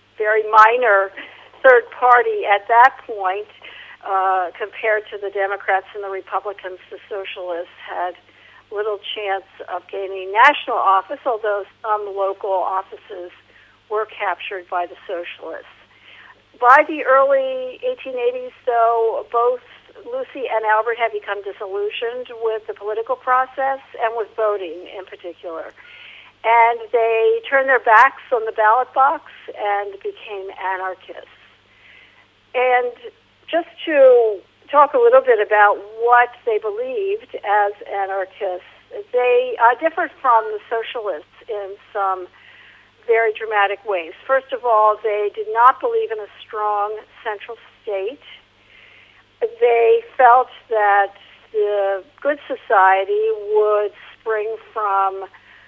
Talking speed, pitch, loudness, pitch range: 120 wpm, 220 Hz, -18 LUFS, 200-260 Hz